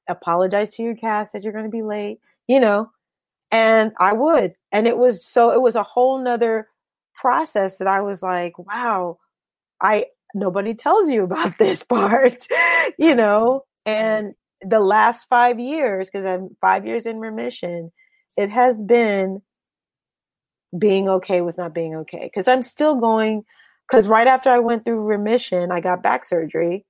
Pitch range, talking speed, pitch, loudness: 190-245 Hz, 165 wpm, 220 Hz, -19 LUFS